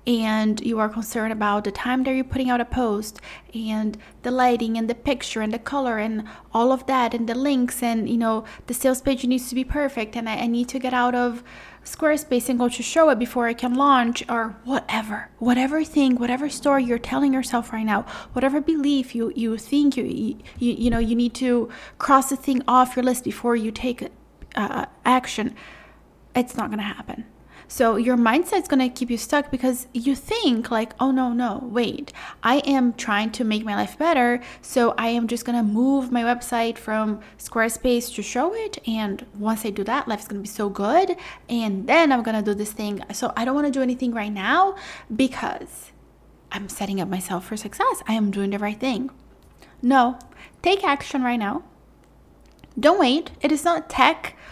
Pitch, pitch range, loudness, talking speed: 245 Hz, 225-265 Hz, -22 LUFS, 200 wpm